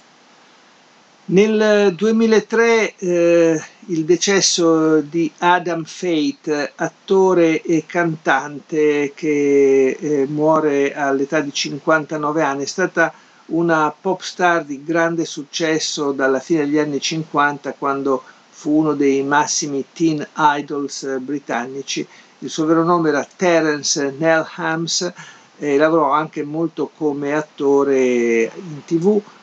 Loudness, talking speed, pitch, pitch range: -18 LUFS, 110 wpm, 155 Hz, 145-170 Hz